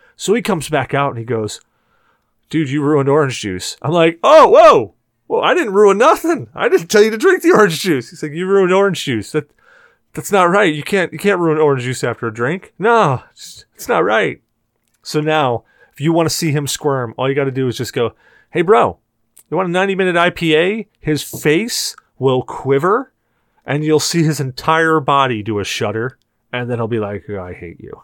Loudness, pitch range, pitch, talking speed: -15 LUFS, 125-175 Hz, 150 Hz, 215 wpm